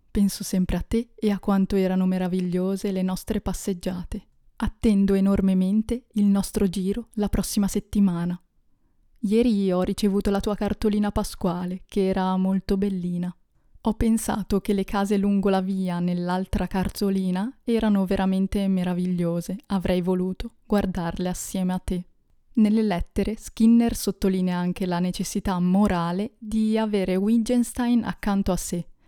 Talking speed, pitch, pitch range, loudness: 135 wpm, 195 Hz, 185-210 Hz, -24 LUFS